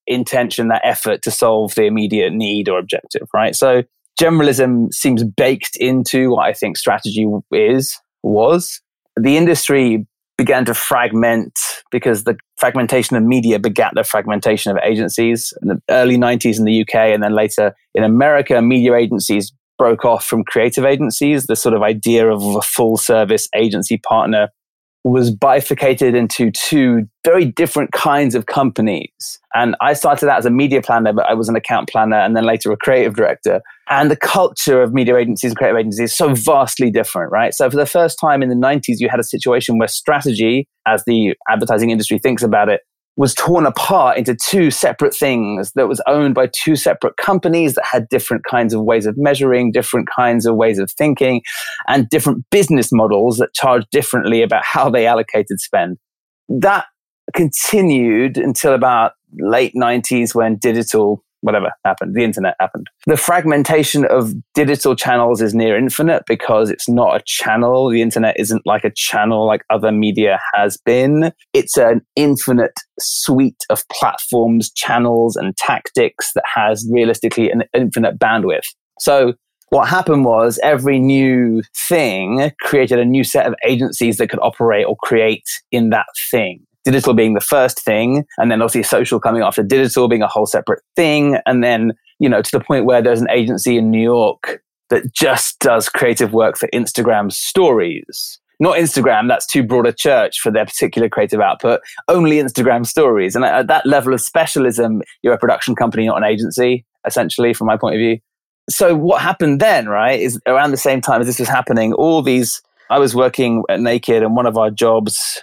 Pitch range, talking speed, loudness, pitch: 115-135 Hz, 180 wpm, -14 LUFS, 120 Hz